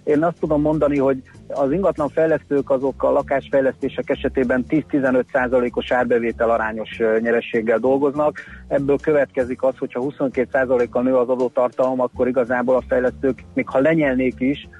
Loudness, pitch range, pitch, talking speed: -20 LUFS, 125-140 Hz, 130 Hz, 135 wpm